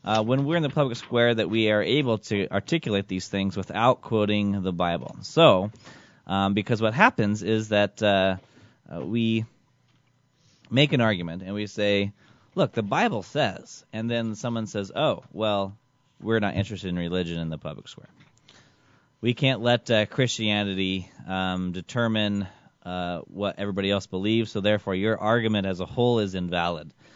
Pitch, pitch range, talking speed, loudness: 105 Hz, 100-120 Hz, 165 wpm, -25 LUFS